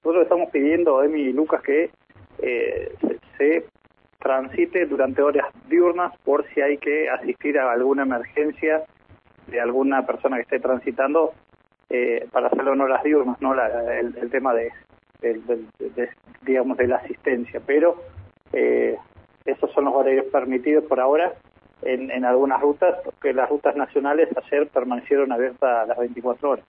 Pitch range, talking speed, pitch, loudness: 125-155 Hz, 165 wpm, 135 Hz, -22 LUFS